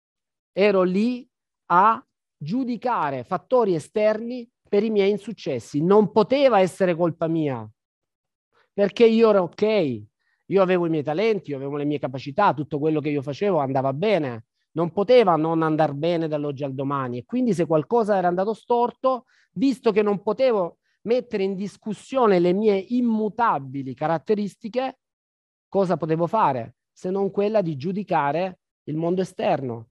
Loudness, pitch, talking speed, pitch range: -22 LUFS, 190 Hz, 145 wpm, 155-220 Hz